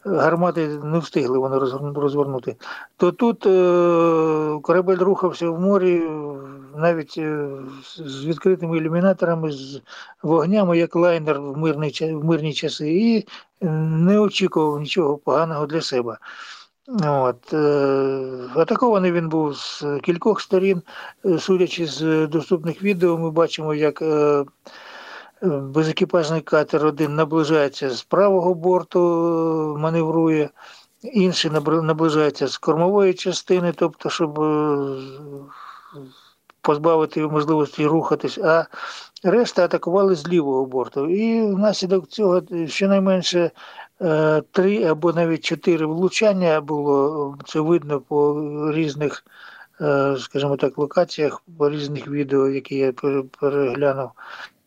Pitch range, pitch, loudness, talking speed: 145-175 Hz, 160 Hz, -20 LUFS, 105 wpm